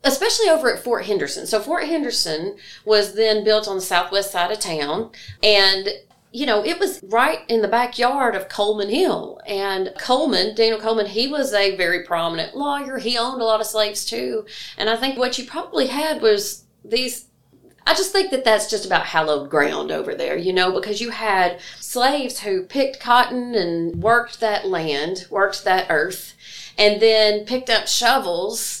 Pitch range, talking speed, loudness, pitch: 200-255 Hz, 180 wpm, -20 LUFS, 220 Hz